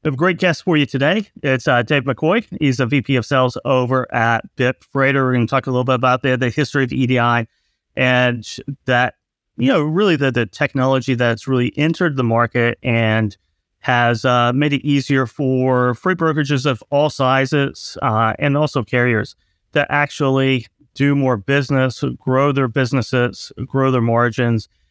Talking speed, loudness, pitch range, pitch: 170 wpm, -17 LUFS, 120-140 Hz, 130 Hz